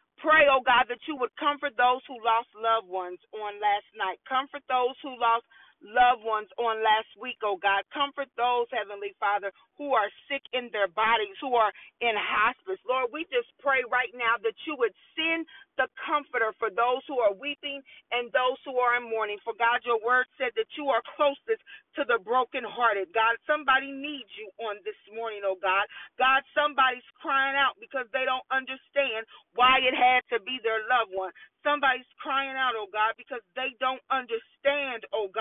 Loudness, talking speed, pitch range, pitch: -27 LUFS, 185 wpm, 225-275 Hz, 250 Hz